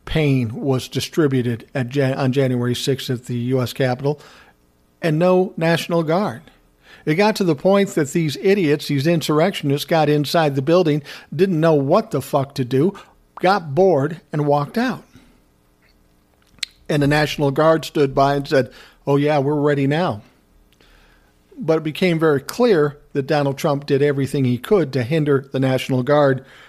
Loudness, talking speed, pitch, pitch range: -19 LUFS, 160 wpm, 145 Hz, 130-160 Hz